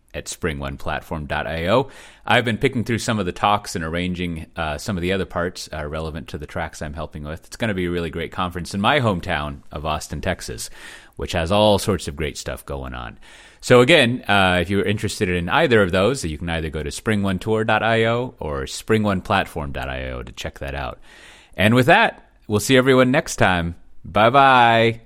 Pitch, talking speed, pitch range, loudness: 90 Hz, 195 wpm, 80-110 Hz, -20 LUFS